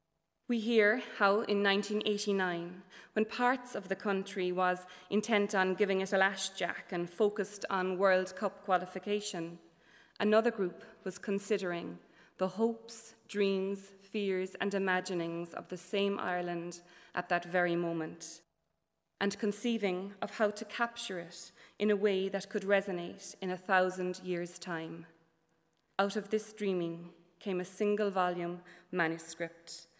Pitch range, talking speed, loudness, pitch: 175-205 Hz, 135 wpm, -34 LUFS, 190 Hz